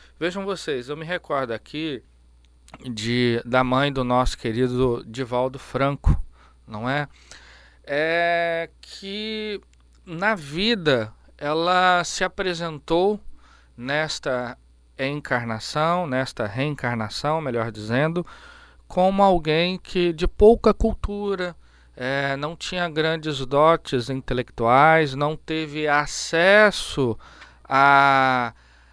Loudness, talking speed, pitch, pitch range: -22 LUFS, 95 wpm, 145 Hz, 125-175 Hz